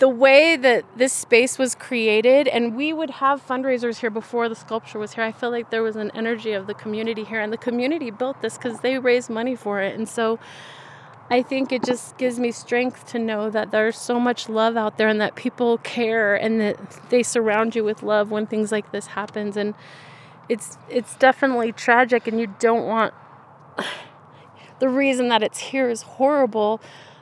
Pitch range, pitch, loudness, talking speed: 215-250 Hz, 230 Hz, -21 LUFS, 200 wpm